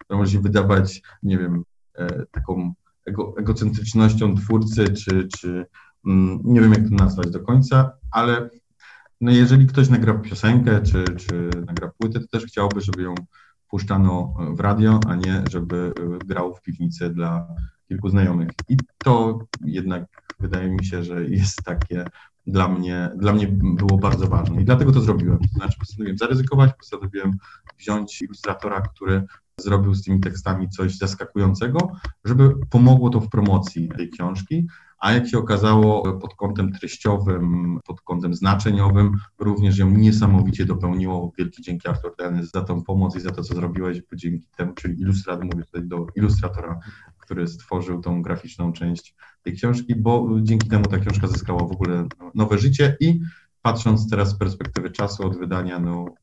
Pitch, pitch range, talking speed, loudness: 95 Hz, 90-110 Hz, 155 wpm, -21 LUFS